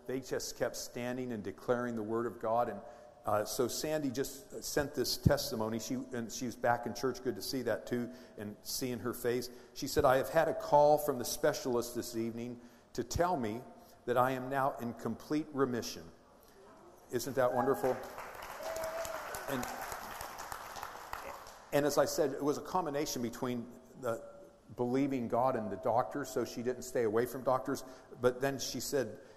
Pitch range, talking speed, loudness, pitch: 120-135 Hz, 175 wpm, -35 LUFS, 125 Hz